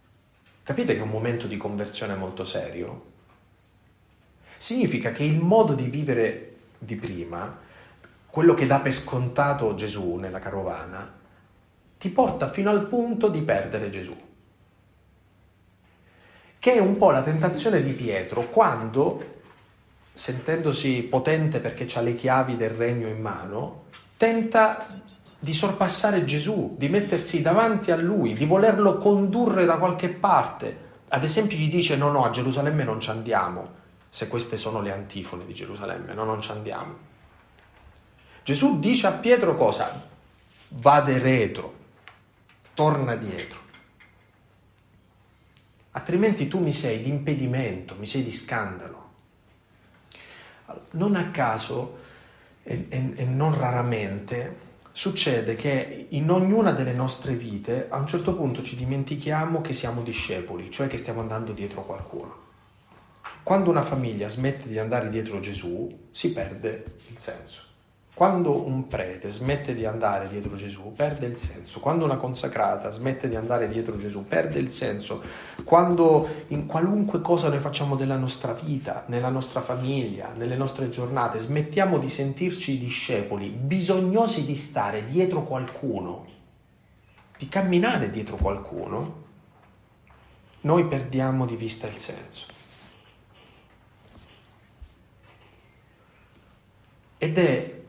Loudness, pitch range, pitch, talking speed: -25 LUFS, 105-155 Hz, 125 Hz, 130 wpm